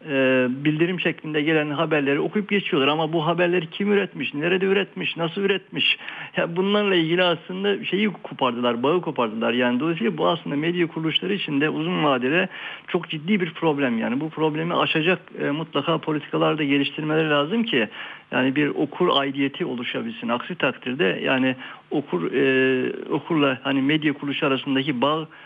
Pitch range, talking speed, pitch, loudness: 140-180 Hz, 155 wpm, 155 Hz, -22 LUFS